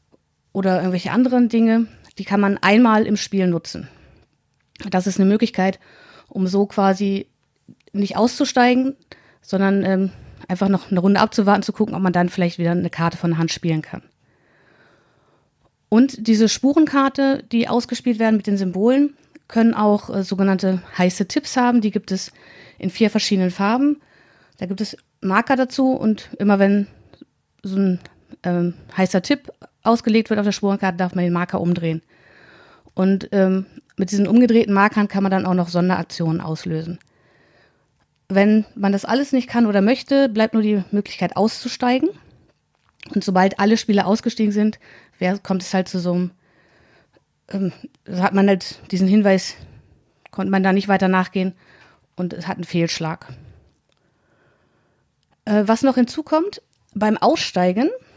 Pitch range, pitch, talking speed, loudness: 185-225 Hz, 200 Hz, 155 wpm, -19 LUFS